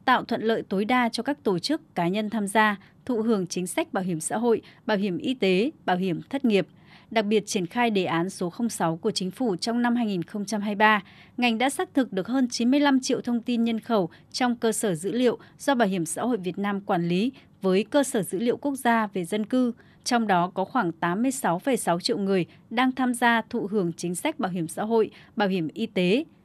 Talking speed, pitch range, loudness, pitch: 230 wpm, 185-240 Hz, -25 LUFS, 215 Hz